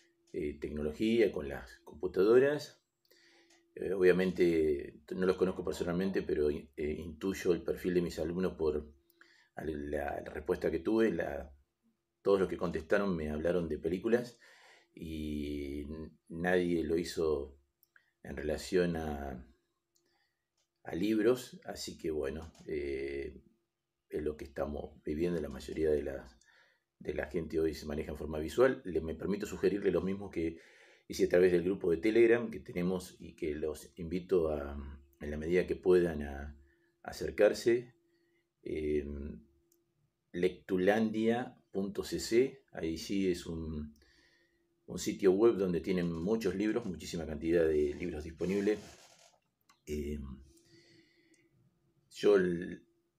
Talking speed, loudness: 130 wpm, -34 LUFS